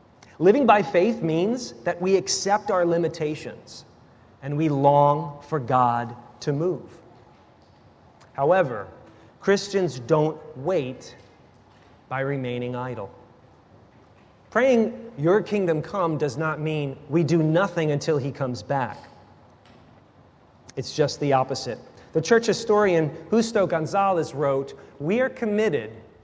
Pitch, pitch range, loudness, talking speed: 155 Hz, 135-185 Hz, -23 LUFS, 115 wpm